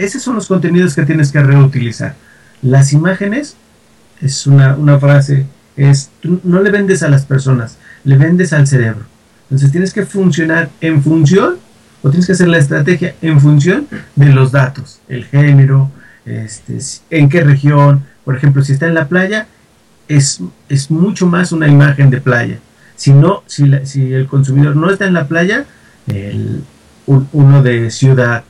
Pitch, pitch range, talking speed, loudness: 145 Hz, 135-170 Hz, 170 wpm, -10 LUFS